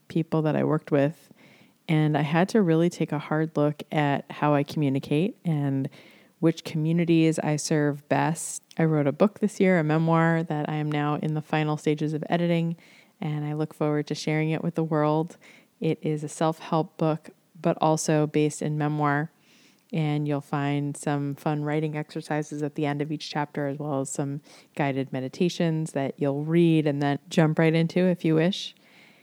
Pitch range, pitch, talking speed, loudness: 150-165 Hz, 155 Hz, 190 wpm, -26 LUFS